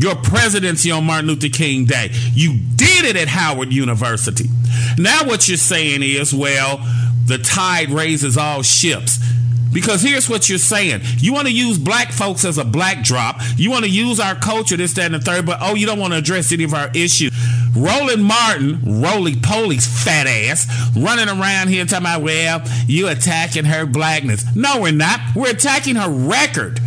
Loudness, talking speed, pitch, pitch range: -14 LUFS, 190 wpm, 150 Hz, 120-180 Hz